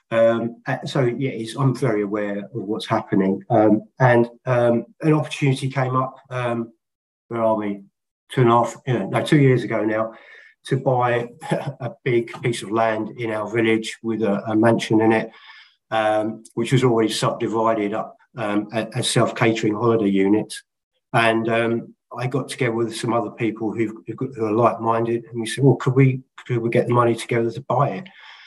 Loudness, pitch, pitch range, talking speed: -21 LUFS, 115 Hz, 110-125 Hz, 190 wpm